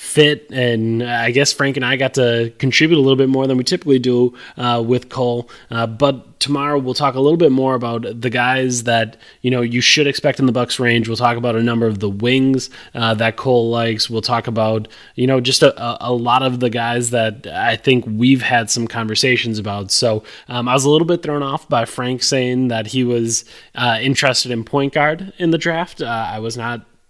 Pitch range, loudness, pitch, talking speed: 115-135 Hz, -16 LUFS, 125 Hz, 225 wpm